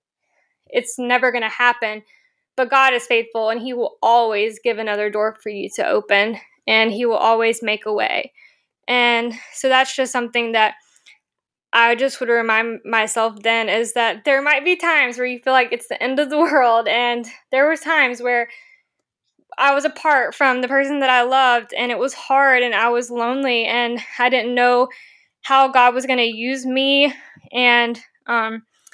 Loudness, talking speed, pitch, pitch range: -17 LUFS, 185 wpm, 245 Hz, 230-270 Hz